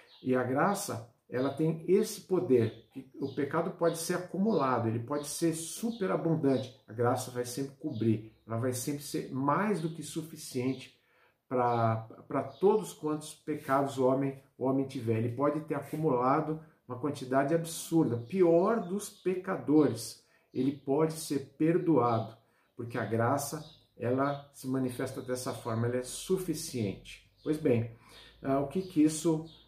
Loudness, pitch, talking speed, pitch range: -32 LUFS, 140 Hz, 145 wpm, 125-160 Hz